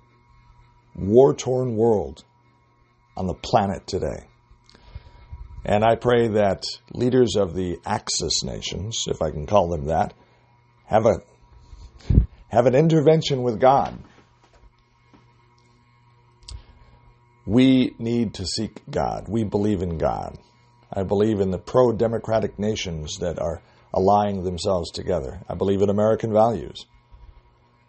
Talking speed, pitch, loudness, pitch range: 120 wpm, 115 Hz, -22 LUFS, 100-120 Hz